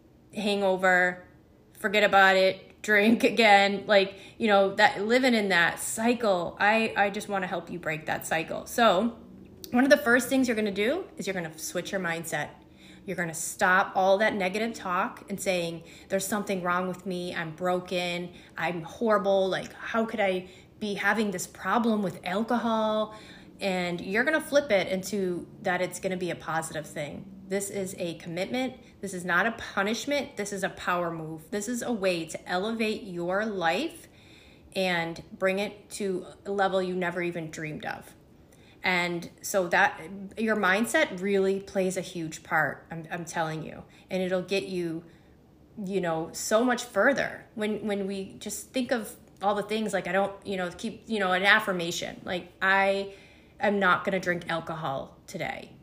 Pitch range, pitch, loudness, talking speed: 180-210 Hz, 195 Hz, -27 LUFS, 180 wpm